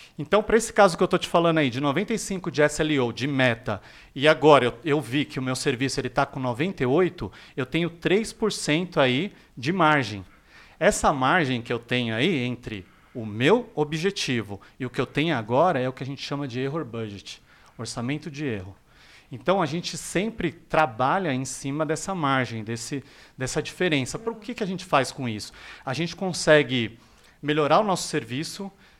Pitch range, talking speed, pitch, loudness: 125-170 Hz, 185 wpm, 145 Hz, -24 LUFS